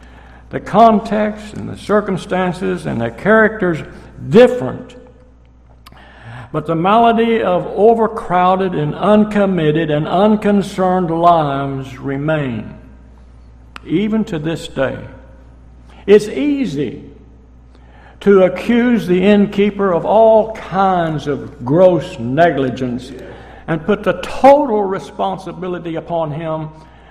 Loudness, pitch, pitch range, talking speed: -14 LUFS, 170 Hz, 130-205 Hz, 95 wpm